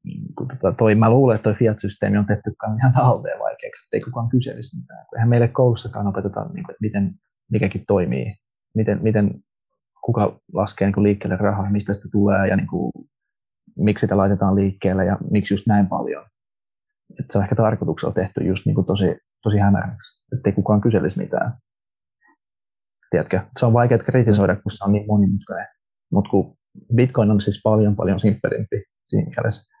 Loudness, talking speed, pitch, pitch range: -20 LUFS, 175 wpm, 105 Hz, 100-120 Hz